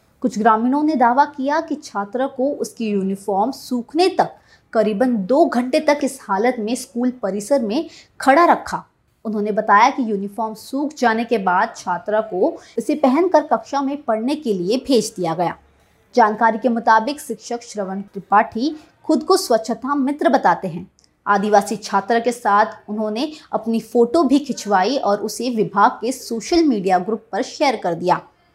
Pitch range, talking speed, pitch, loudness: 210-275 Hz, 160 wpm, 230 Hz, -19 LUFS